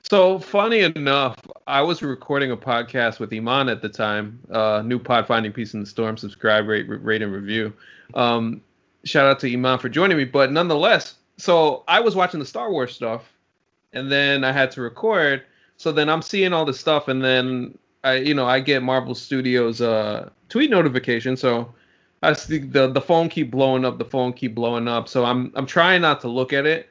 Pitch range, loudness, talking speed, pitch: 115-140 Hz, -20 LUFS, 205 wpm, 130 Hz